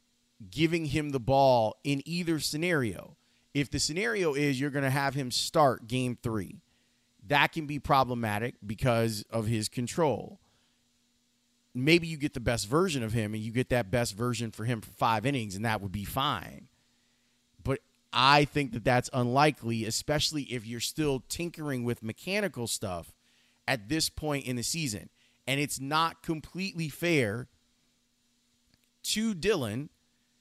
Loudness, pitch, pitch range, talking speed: -29 LUFS, 125 Hz, 120-145 Hz, 155 wpm